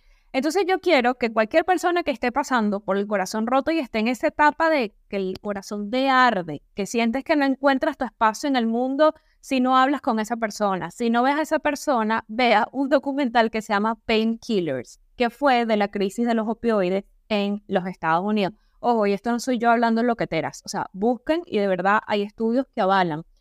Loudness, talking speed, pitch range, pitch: -22 LUFS, 215 wpm, 205-270 Hz, 230 Hz